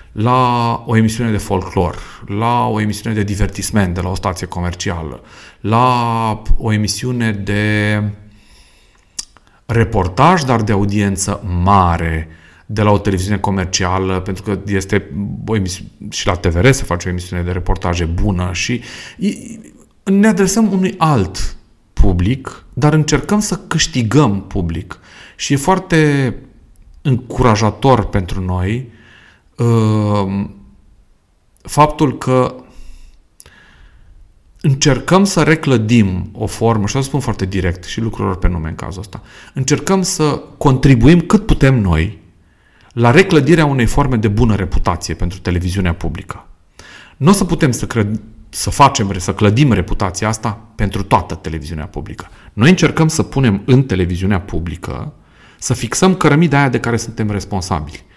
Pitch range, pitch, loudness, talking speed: 95-125 Hz, 105 Hz, -15 LUFS, 130 wpm